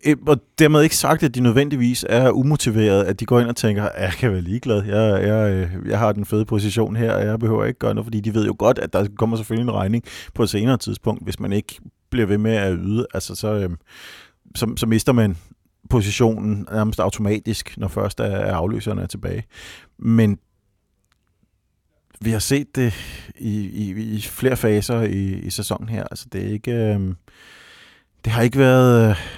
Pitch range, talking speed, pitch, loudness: 100-115 Hz, 190 wpm, 110 Hz, -20 LUFS